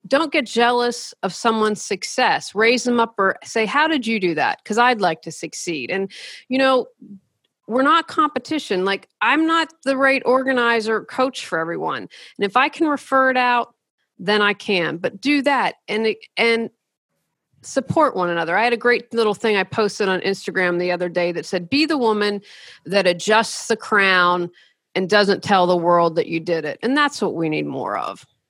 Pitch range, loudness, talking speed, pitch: 185-255 Hz, -19 LUFS, 195 wpm, 220 Hz